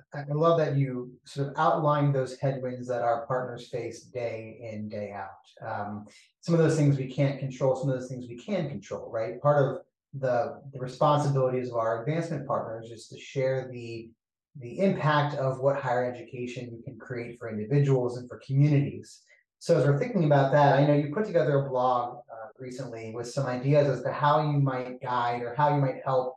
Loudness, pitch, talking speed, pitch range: -27 LUFS, 130 Hz, 205 wpm, 120-145 Hz